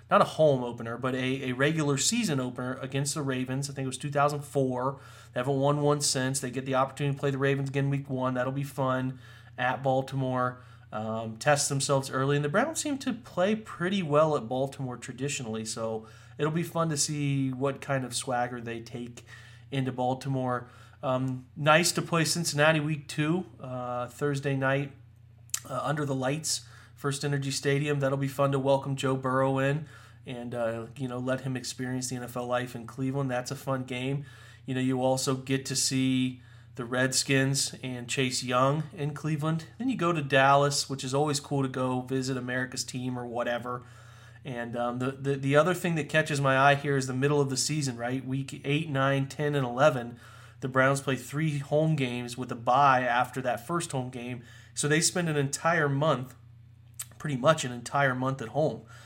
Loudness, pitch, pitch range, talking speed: -28 LUFS, 135 Hz, 125-145 Hz, 195 wpm